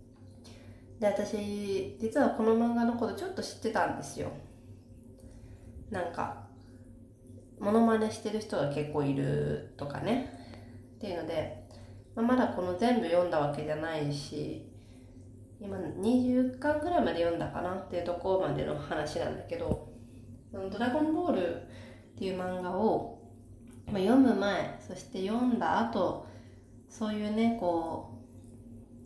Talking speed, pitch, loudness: 260 characters per minute, 155 Hz, -31 LUFS